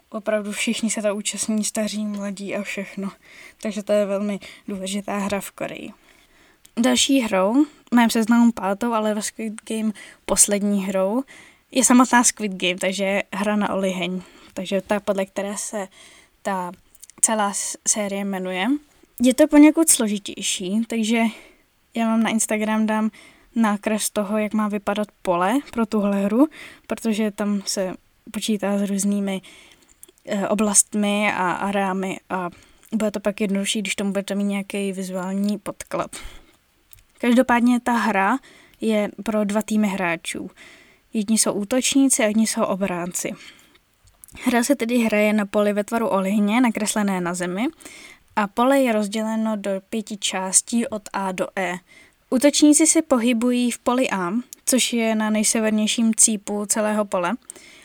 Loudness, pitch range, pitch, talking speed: -21 LUFS, 200-235 Hz, 215 Hz, 140 wpm